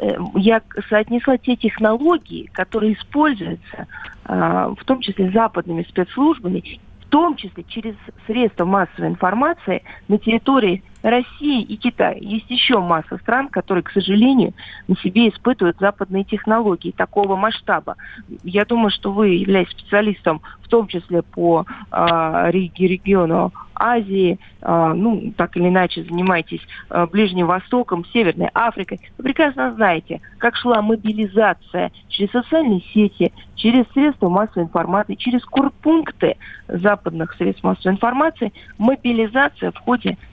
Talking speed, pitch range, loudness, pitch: 125 wpm, 185-240 Hz, -18 LUFS, 210 Hz